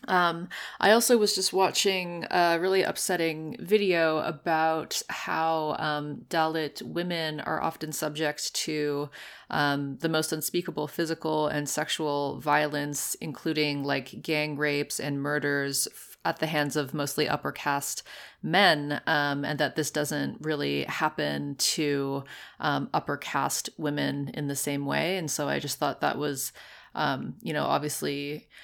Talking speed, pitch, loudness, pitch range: 145 wpm, 150 Hz, -28 LUFS, 145-165 Hz